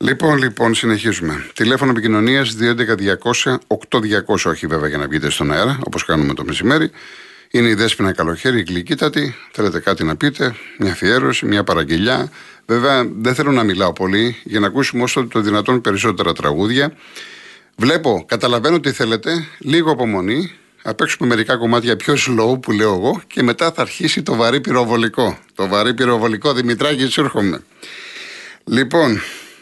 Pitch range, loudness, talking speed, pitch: 105-135 Hz, -16 LUFS, 150 wpm, 120 Hz